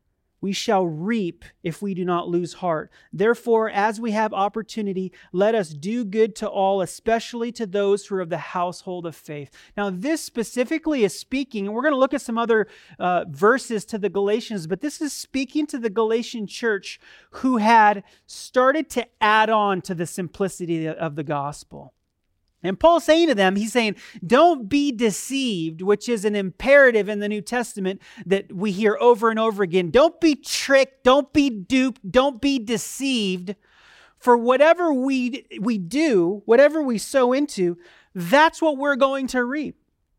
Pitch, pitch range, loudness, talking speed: 220 Hz, 195-260 Hz, -21 LUFS, 175 wpm